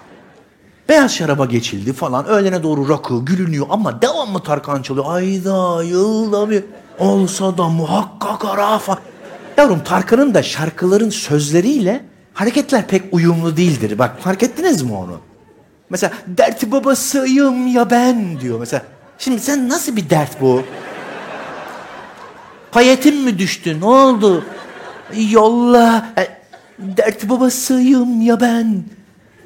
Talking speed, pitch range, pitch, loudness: 120 wpm, 170-245 Hz, 200 Hz, -15 LUFS